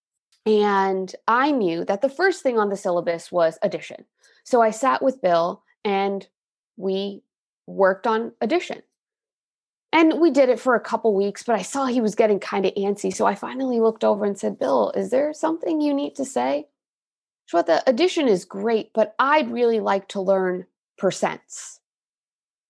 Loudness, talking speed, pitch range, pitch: -22 LUFS, 175 wpm, 195-265 Hz, 220 Hz